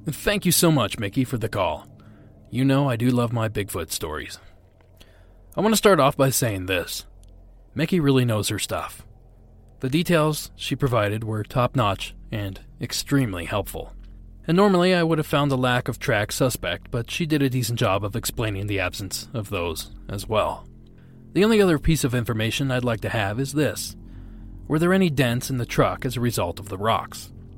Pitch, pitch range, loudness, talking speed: 115 Hz, 100-140 Hz, -23 LUFS, 190 wpm